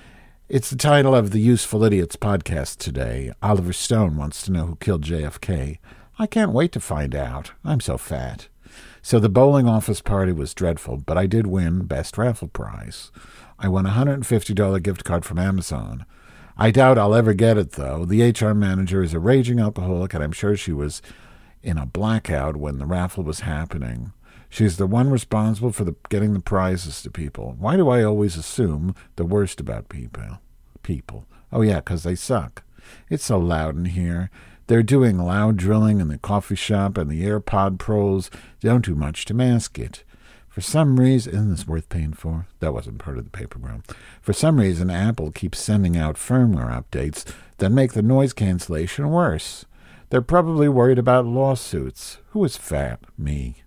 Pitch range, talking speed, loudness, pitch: 85-115 Hz, 185 wpm, -21 LUFS, 100 Hz